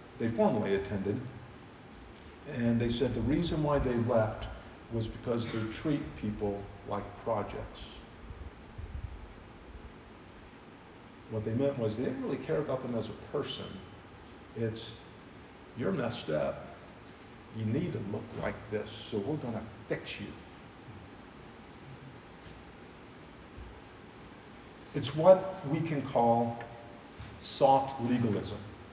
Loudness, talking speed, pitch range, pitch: -33 LUFS, 110 wpm, 100-120 Hz, 115 Hz